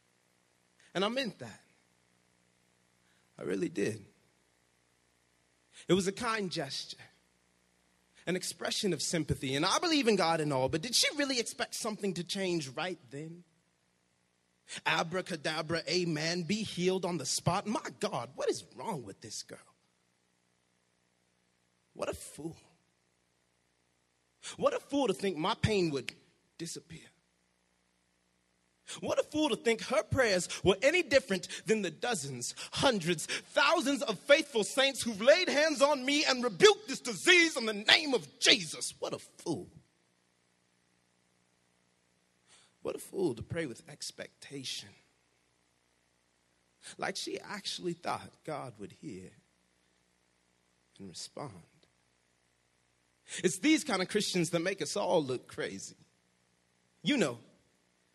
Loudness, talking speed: -31 LUFS, 130 wpm